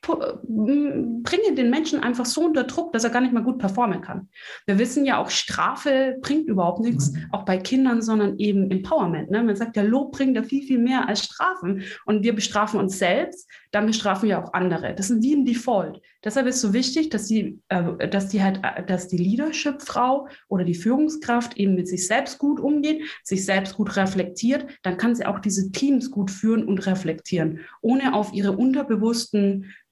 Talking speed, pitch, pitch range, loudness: 195 wpm, 220 Hz, 195-260 Hz, -23 LUFS